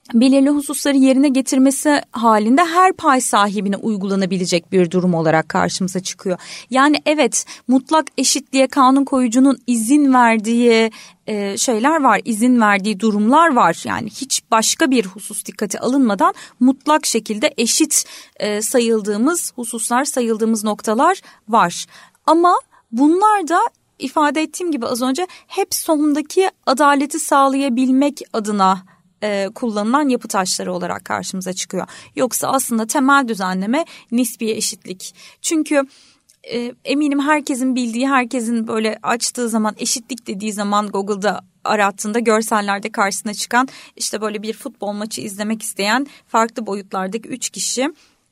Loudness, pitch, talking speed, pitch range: -17 LUFS, 240 Hz, 120 wpm, 210-280 Hz